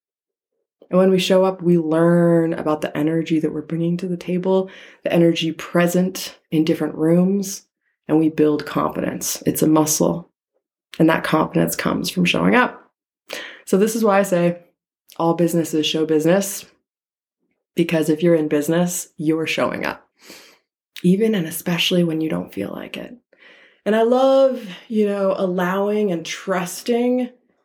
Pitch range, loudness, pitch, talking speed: 160-195 Hz, -19 LUFS, 175 Hz, 155 wpm